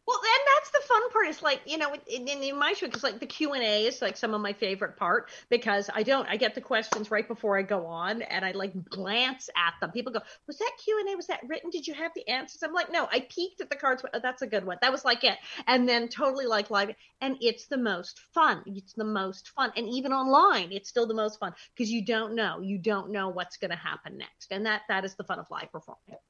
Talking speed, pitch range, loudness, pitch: 265 wpm, 205-290 Hz, -28 LUFS, 235 Hz